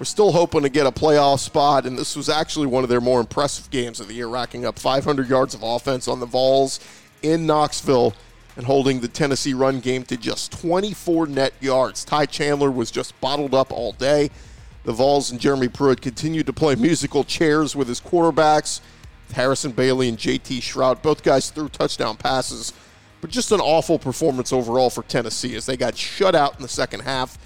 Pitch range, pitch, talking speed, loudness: 120-150 Hz, 135 Hz, 200 wpm, -20 LUFS